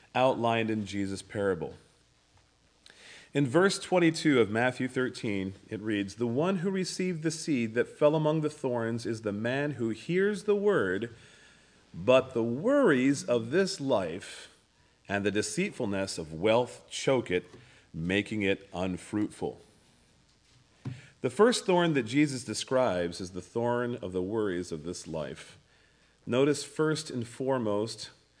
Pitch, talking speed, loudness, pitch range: 120 Hz, 135 wpm, -29 LUFS, 105-150 Hz